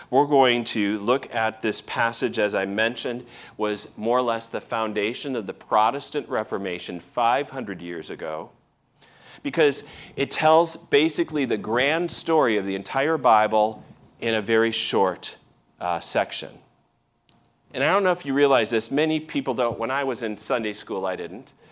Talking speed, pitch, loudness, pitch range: 165 wpm, 115 Hz, -23 LUFS, 110-140 Hz